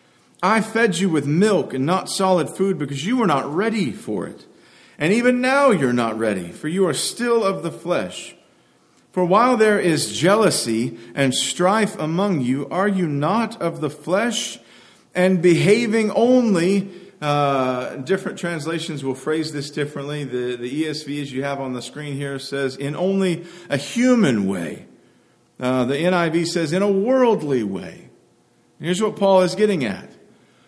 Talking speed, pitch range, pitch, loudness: 165 wpm, 140-200 Hz, 175 Hz, -20 LUFS